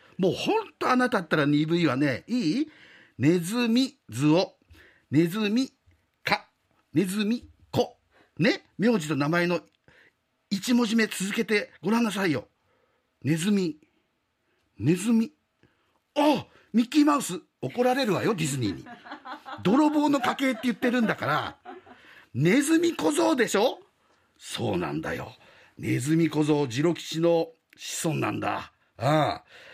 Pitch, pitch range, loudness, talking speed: 210 Hz, 160-255 Hz, -26 LUFS, 250 characters per minute